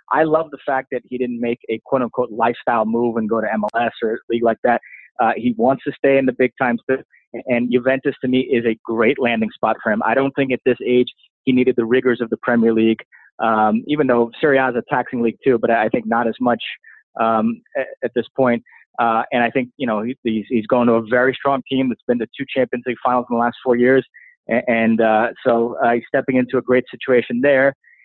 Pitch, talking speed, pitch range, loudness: 125 Hz, 240 wpm, 115-130 Hz, -18 LUFS